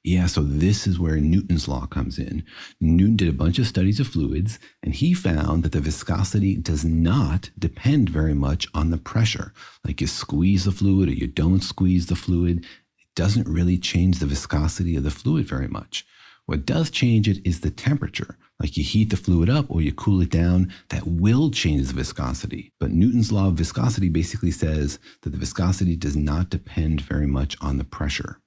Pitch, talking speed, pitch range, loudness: 90 Hz, 200 wpm, 80-100 Hz, -22 LUFS